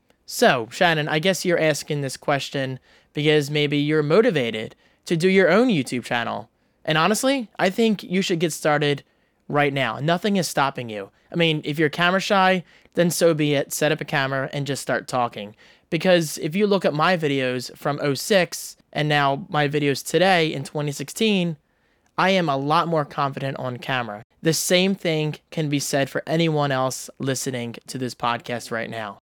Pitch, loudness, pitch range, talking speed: 150 Hz, -22 LUFS, 135-175 Hz, 180 wpm